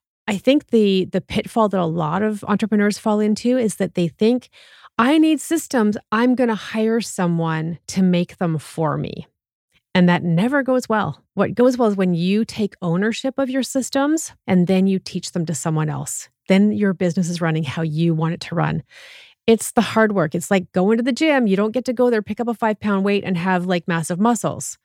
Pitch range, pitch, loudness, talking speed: 180-230 Hz, 205 Hz, -19 LUFS, 220 wpm